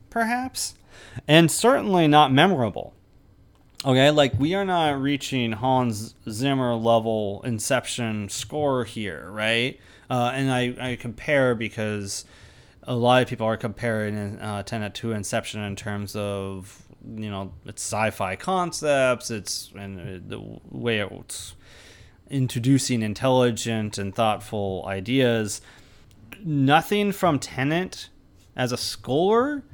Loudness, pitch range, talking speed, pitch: -23 LUFS, 105-135 Hz, 115 wpm, 115 Hz